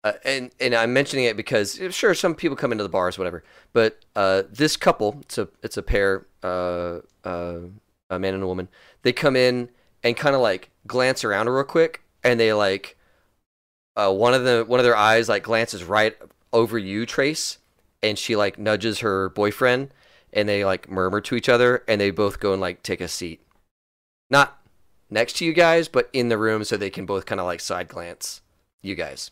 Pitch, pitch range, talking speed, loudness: 110 Hz, 95-125 Hz, 205 wpm, -22 LUFS